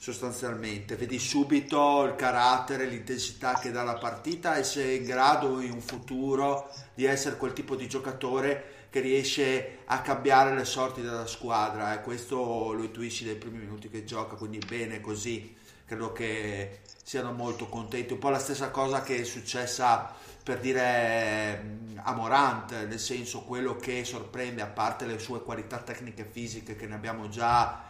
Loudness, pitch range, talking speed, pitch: -30 LUFS, 115-130 Hz, 170 wpm, 120 Hz